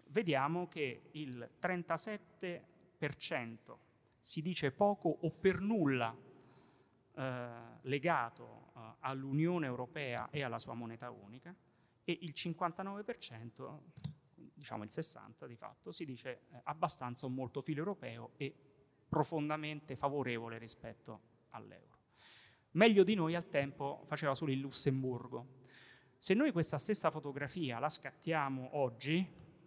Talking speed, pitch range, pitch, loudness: 115 wpm, 125-165 Hz, 140 Hz, -38 LUFS